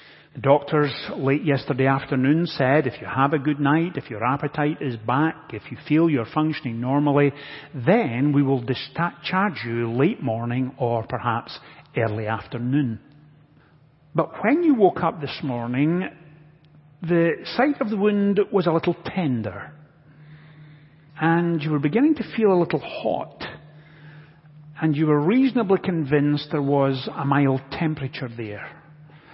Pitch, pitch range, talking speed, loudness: 150 Hz, 135-160 Hz, 140 wpm, -22 LUFS